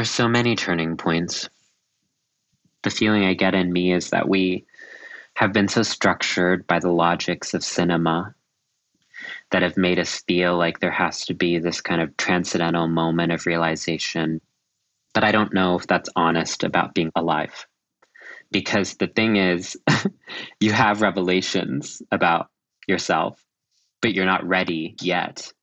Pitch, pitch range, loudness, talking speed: 90 Hz, 85-95 Hz, -21 LUFS, 150 wpm